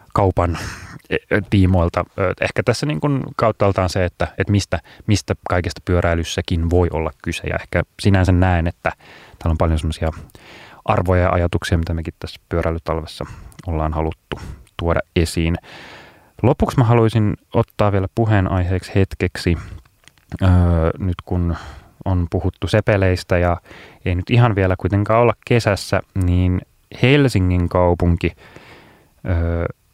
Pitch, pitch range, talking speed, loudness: 90 Hz, 85-100 Hz, 120 wpm, -19 LUFS